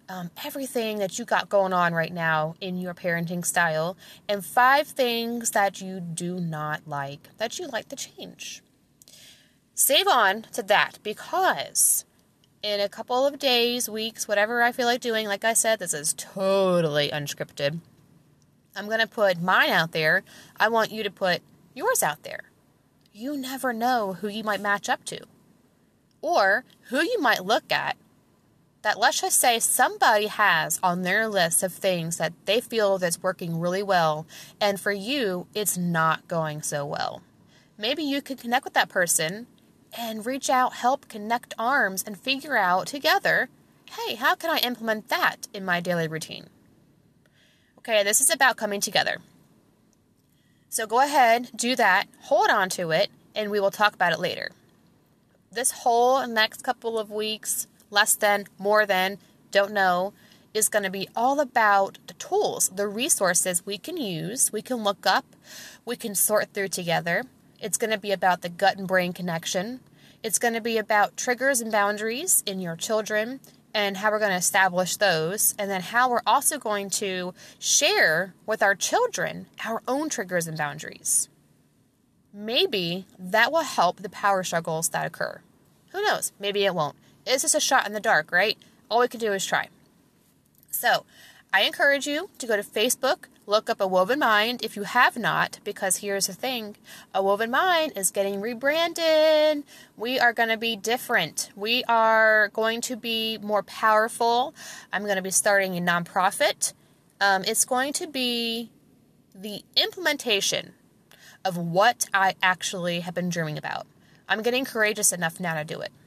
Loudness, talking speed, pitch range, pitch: -24 LUFS, 170 wpm, 185-240 Hz, 210 Hz